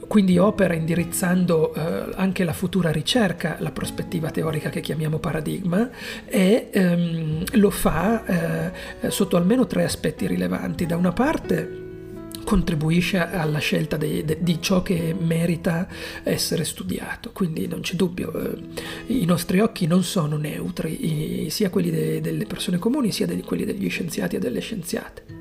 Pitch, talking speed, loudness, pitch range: 175 Hz, 130 wpm, -23 LUFS, 165-200 Hz